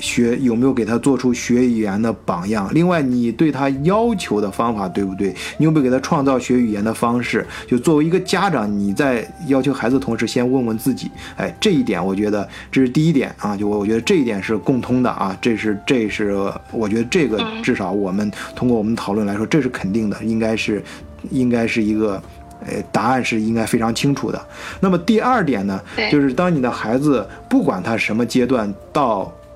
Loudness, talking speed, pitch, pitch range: -18 LUFS, 315 characters per minute, 115 Hz, 105-135 Hz